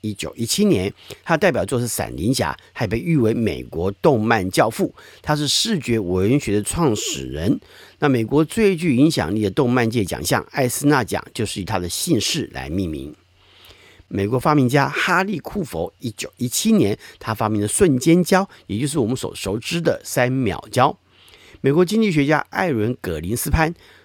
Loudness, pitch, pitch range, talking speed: -20 LUFS, 120 Hz, 105-150 Hz, 265 characters per minute